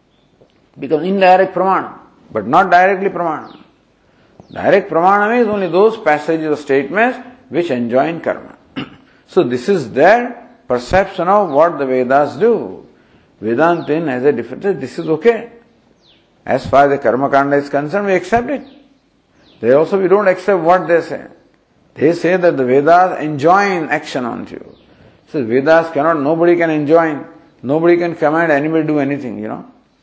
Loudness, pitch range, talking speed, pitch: -14 LUFS, 145-200 Hz, 155 wpm, 170 Hz